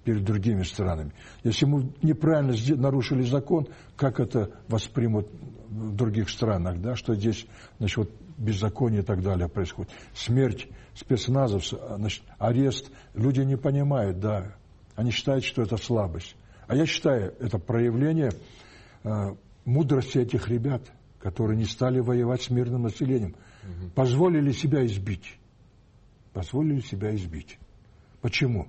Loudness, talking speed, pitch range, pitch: -27 LUFS, 125 wpm, 105-130 Hz, 115 Hz